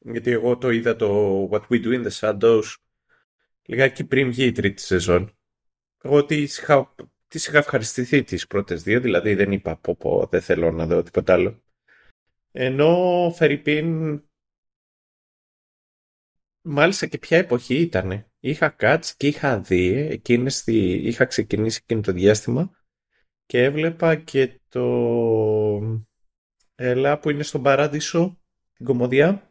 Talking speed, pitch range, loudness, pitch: 135 wpm, 105-145 Hz, -21 LUFS, 125 Hz